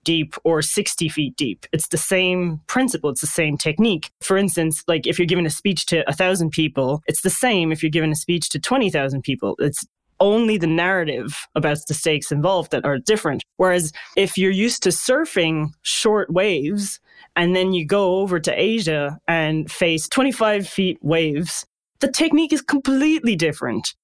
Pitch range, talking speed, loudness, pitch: 155-200 Hz, 180 wpm, -19 LUFS, 175 Hz